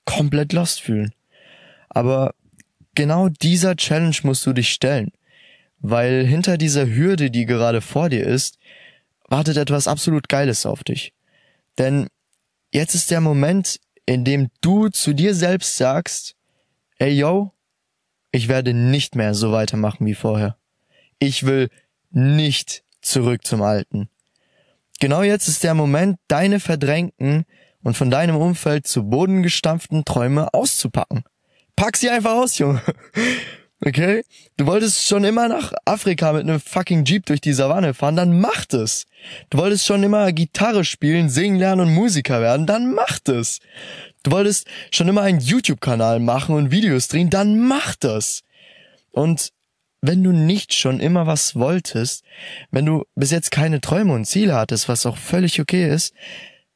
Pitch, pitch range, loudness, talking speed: 150 Hz, 130-180 Hz, -18 LUFS, 150 wpm